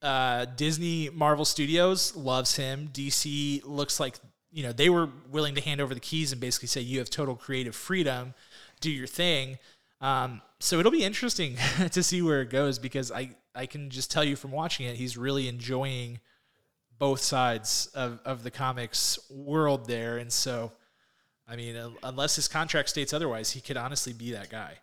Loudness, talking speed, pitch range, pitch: -29 LUFS, 185 wpm, 125-150 Hz, 135 Hz